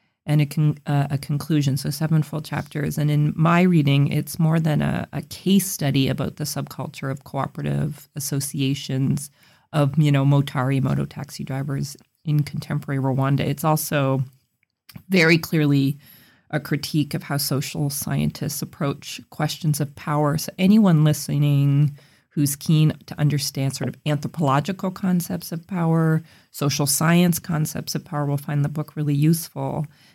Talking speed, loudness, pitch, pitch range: 150 wpm, -22 LUFS, 150 Hz, 140-160 Hz